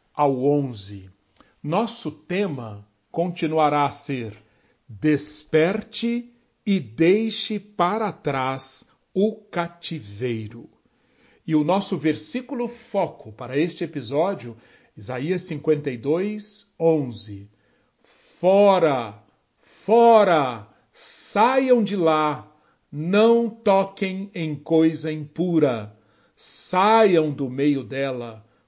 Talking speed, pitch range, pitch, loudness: 80 wpm, 130-195 Hz, 155 Hz, -22 LUFS